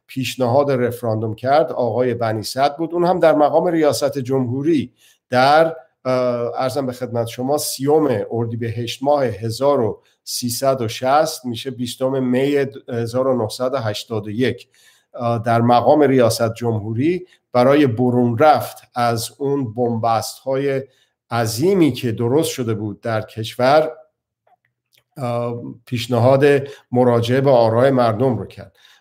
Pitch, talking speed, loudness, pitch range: 125 Hz, 110 wpm, -18 LUFS, 115-140 Hz